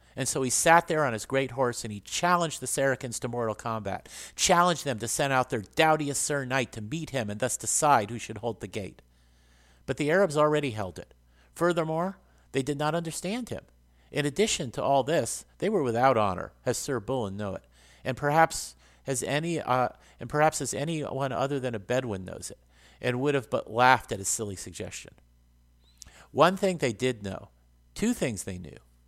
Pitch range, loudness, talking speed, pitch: 95-145 Hz, -28 LUFS, 200 wpm, 125 Hz